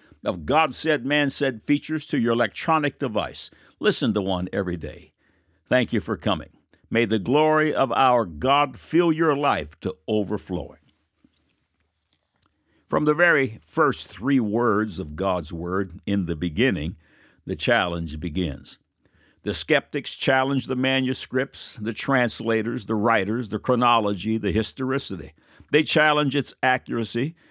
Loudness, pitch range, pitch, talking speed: -23 LUFS, 95-135 Hz, 115 Hz, 135 wpm